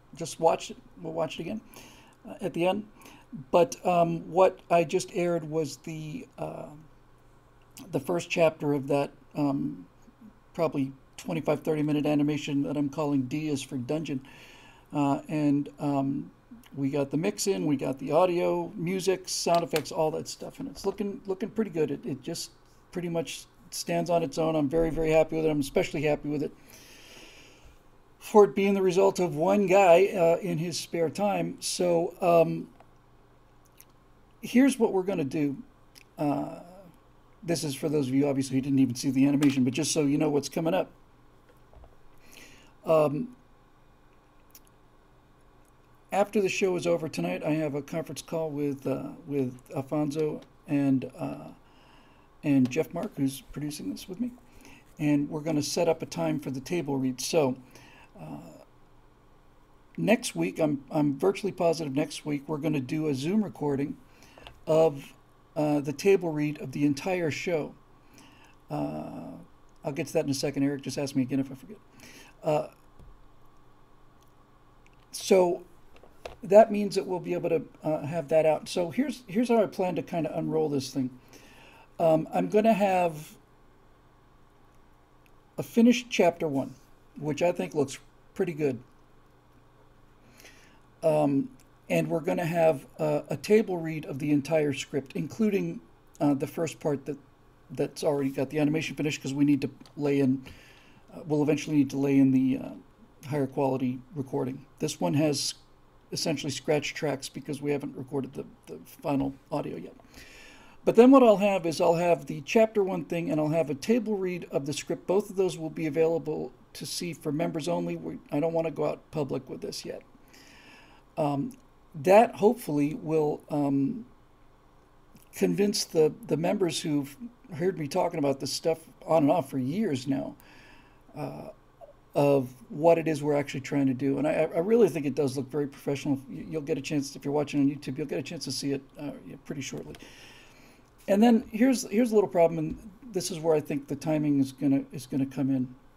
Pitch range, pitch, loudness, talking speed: 140-170 Hz, 155 Hz, -28 LUFS, 175 wpm